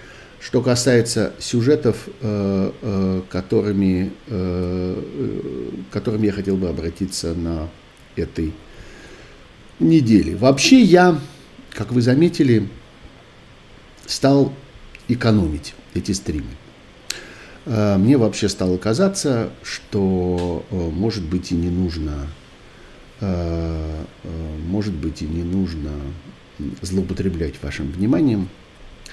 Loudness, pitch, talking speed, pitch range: -20 LUFS, 95 Hz, 80 wpm, 85-110 Hz